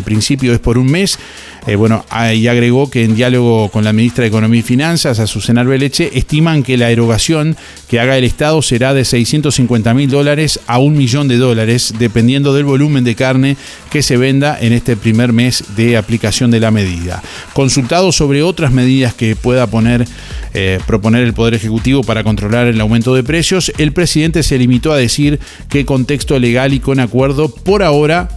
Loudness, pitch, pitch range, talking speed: -11 LUFS, 125 Hz, 115-140 Hz, 185 wpm